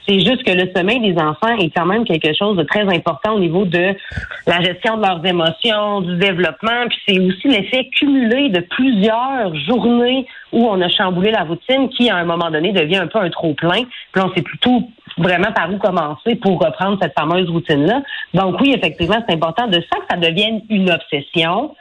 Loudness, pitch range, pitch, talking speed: -16 LUFS, 175-230 Hz, 195 Hz, 205 wpm